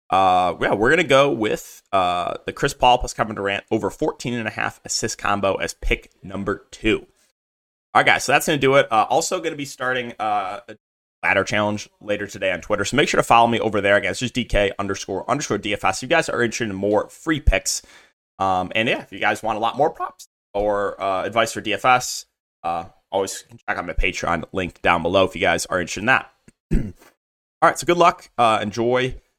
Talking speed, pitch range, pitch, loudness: 220 wpm, 95-125 Hz, 105 Hz, -21 LUFS